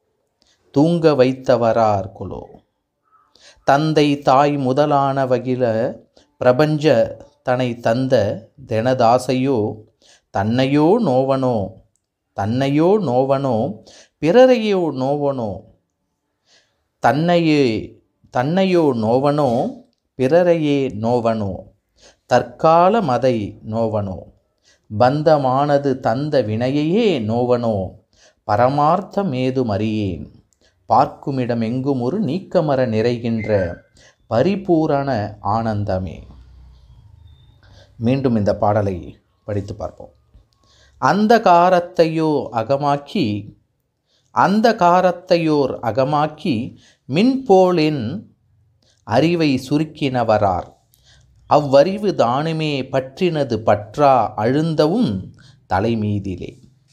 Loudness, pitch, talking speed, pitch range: -17 LUFS, 130 Hz, 60 wpm, 110-150 Hz